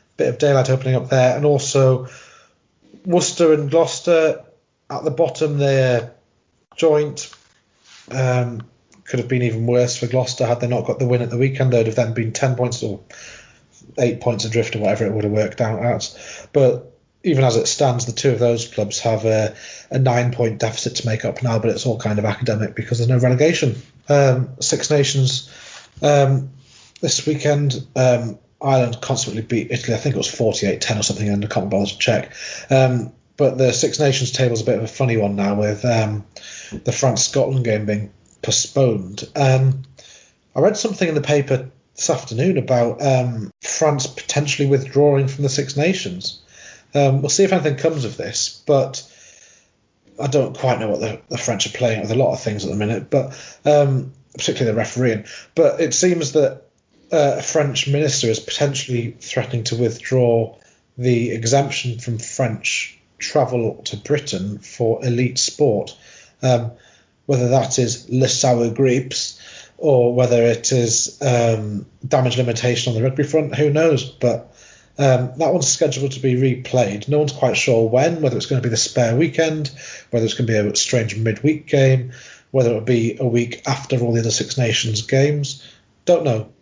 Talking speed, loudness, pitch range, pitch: 185 wpm, -19 LUFS, 115-140 Hz, 125 Hz